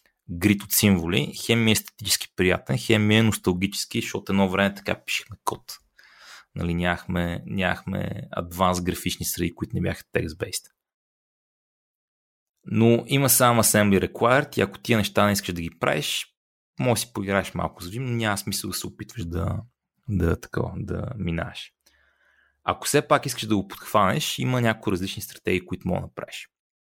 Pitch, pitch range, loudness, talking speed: 100 Hz, 90-110 Hz, -24 LUFS, 160 wpm